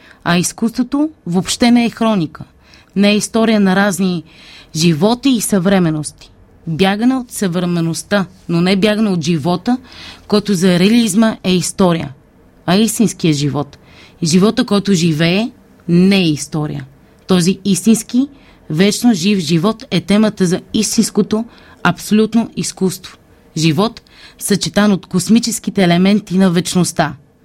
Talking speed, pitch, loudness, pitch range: 120 wpm, 195 Hz, -14 LUFS, 175-215 Hz